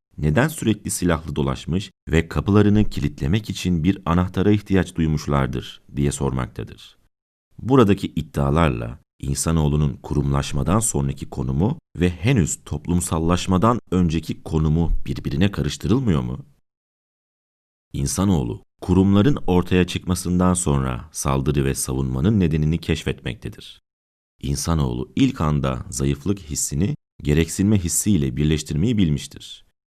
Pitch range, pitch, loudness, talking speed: 70-95 Hz, 80 Hz, -21 LUFS, 95 wpm